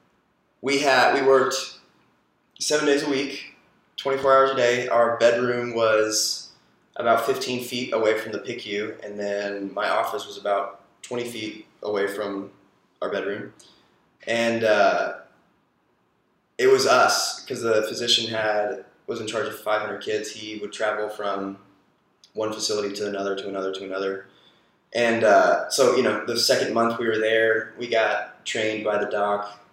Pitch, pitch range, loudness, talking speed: 110 Hz, 100-120 Hz, -23 LUFS, 160 wpm